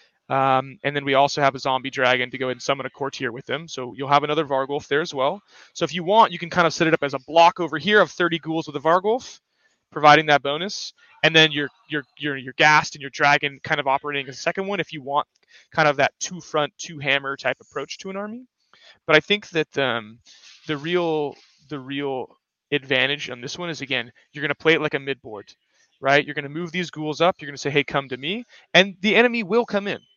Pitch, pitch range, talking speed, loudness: 150 Hz, 140-170 Hz, 250 wpm, -21 LUFS